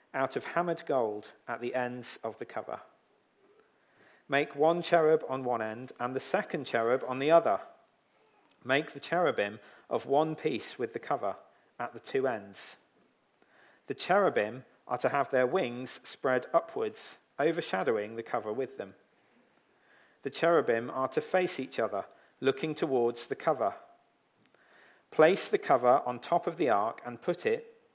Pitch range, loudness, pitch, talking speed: 125-170 Hz, -31 LUFS, 135 Hz, 155 wpm